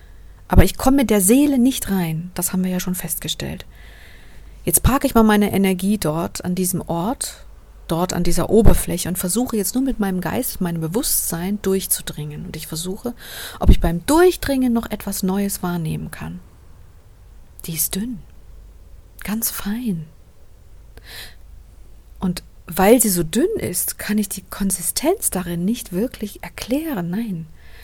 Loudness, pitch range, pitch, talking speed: -20 LUFS, 155-215 Hz, 180 Hz, 150 wpm